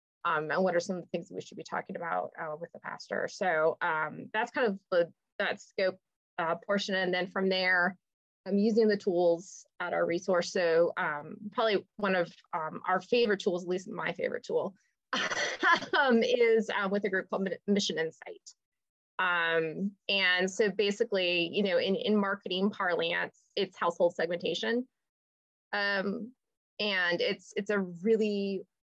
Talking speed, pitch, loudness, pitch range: 165 wpm, 200 Hz, -30 LUFS, 180-220 Hz